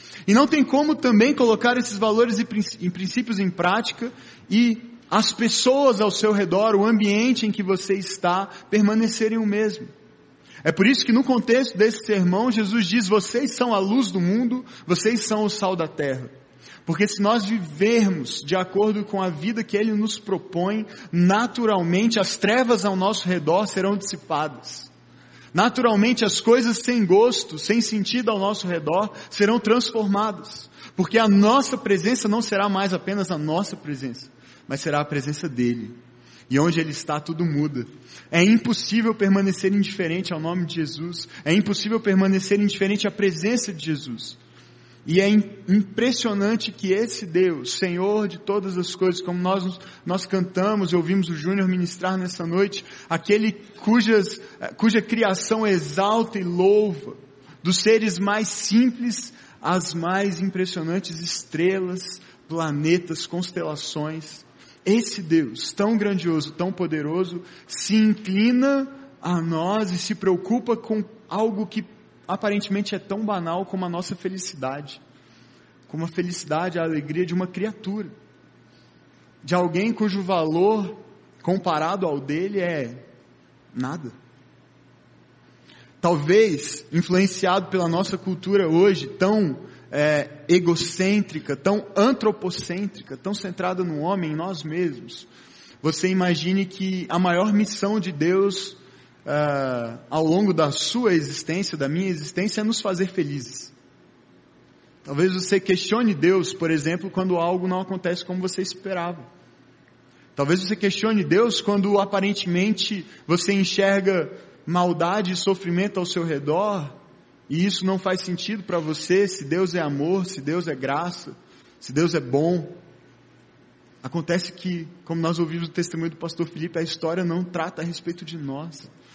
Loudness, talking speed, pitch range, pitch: -22 LUFS, 140 wpm, 170-210 Hz, 190 Hz